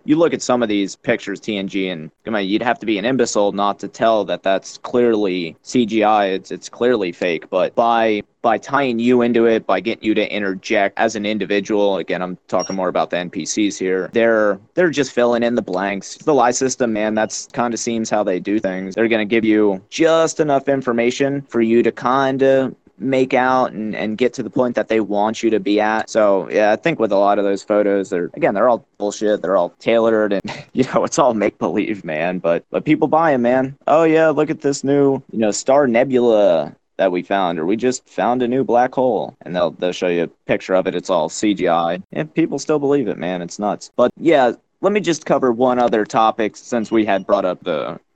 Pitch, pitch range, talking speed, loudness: 110 Hz, 100-130 Hz, 230 wpm, -18 LUFS